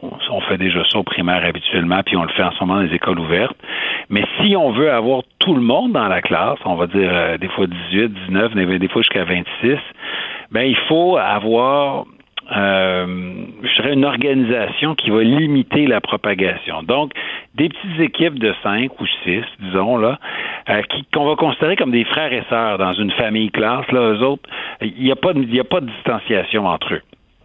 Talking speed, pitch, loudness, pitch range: 205 wpm, 115 Hz, -17 LUFS, 95-135 Hz